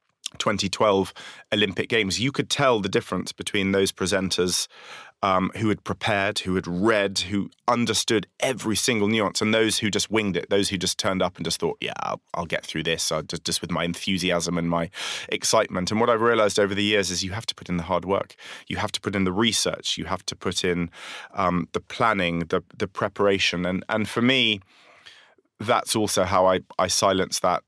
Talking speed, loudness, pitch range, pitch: 205 wpm, -23 LUFS, 90-105 Hz, 95 Hz